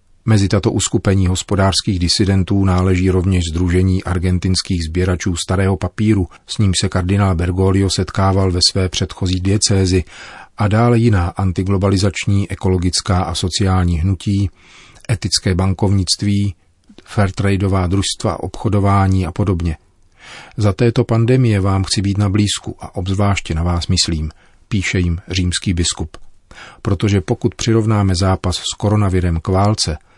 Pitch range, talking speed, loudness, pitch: 90-100 Hz, 125 wpm, -16 LUFS, 95 Hz